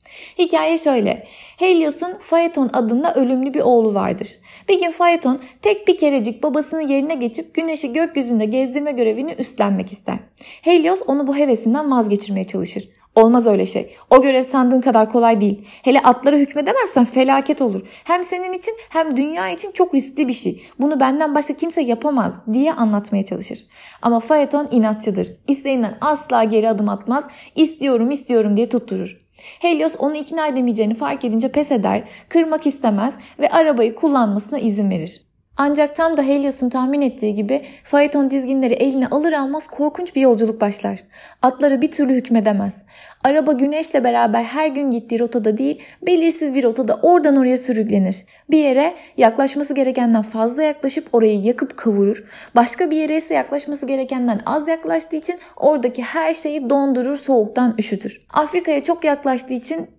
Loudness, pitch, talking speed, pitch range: -17 LUFS, 275 Hz, 150 wpm, 235-305 Hz